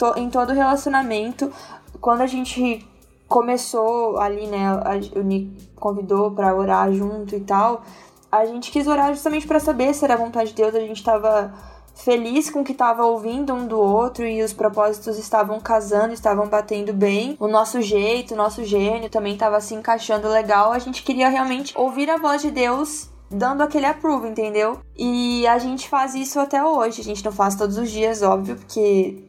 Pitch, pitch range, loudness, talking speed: 225 Hz, 210-255 Hz, -20 LUFS, 180 wpm